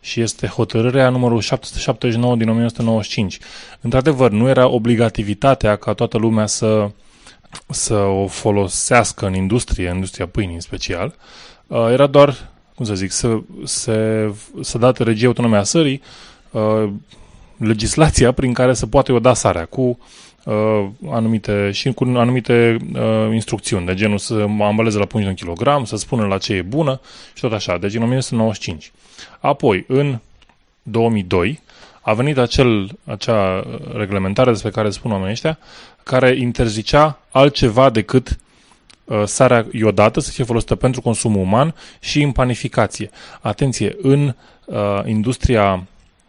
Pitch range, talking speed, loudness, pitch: 105-125 Hz, 135 wpm, -17 LUFS, 115 Hz